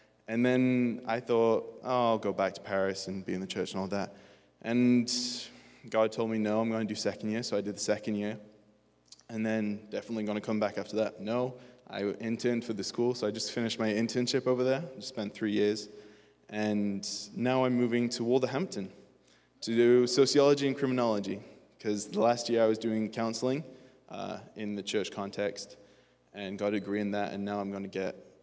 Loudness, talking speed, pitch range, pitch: -31 LUFS, 205 wpm, 100-120 Hz, 110 Hz